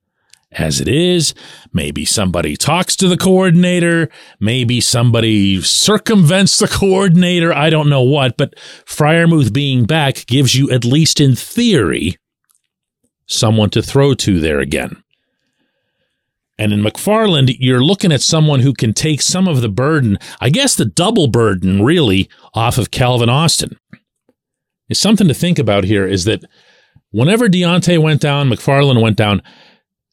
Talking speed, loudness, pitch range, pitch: 145 wpm, -12 LUFS, 115-170 Hz, 140 Hz